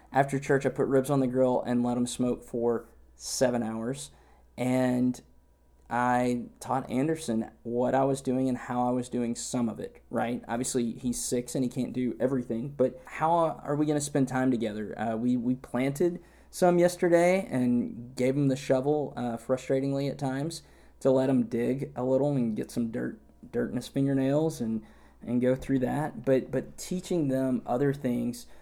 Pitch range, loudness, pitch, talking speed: 120-135 Hz, -29 LUFS, 125 Hz, 185 wpm